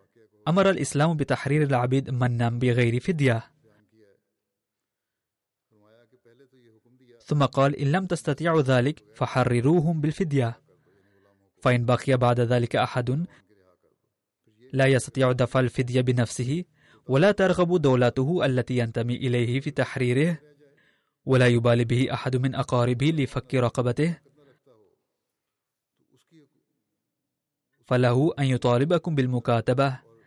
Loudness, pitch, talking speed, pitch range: -24 LUFS, 130 Hz, 90 wpm, 120-145 Hz